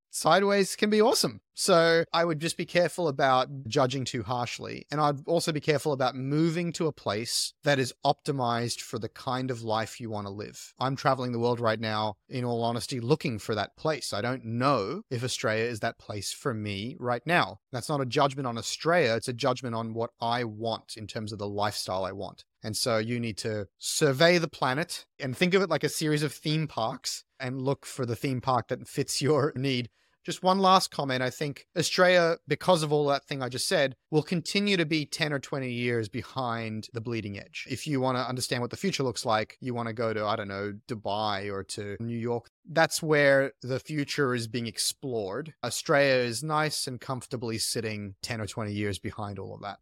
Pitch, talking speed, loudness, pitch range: 125 Hz, 215 wpm, -28 LUFS, 115-150 Hz